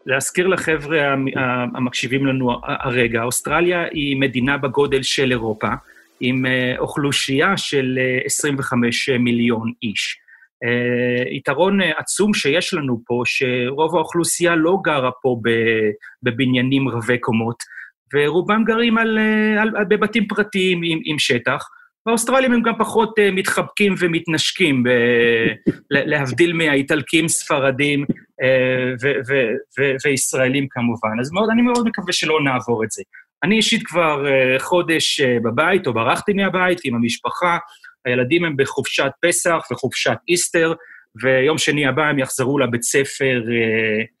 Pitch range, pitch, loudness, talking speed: 125-180 Hz, 140 Hz, -18 LUFS, 125 wpm